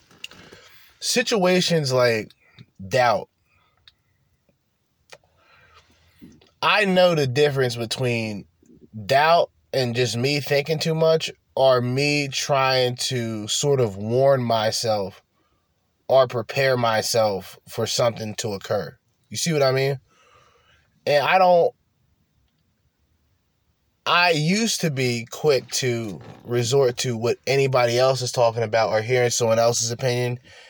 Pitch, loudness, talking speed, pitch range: 125 Hz, -21 LUFS, 110 wpm, 115-140 Hz